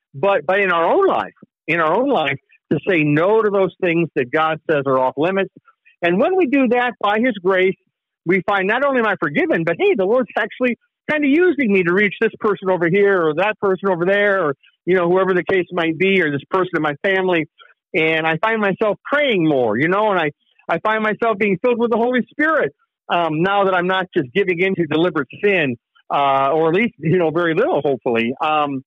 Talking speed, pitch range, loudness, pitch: 230 wpm, 165-215 Hz, -17 LUFS, 190 Hz